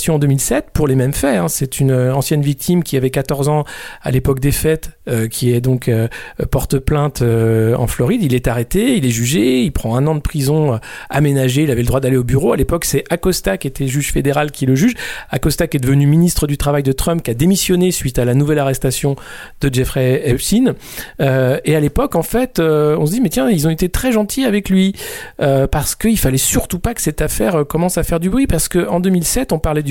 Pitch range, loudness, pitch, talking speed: 130-170 Hz, -15 LUFS, 145 Hz, 240 wpm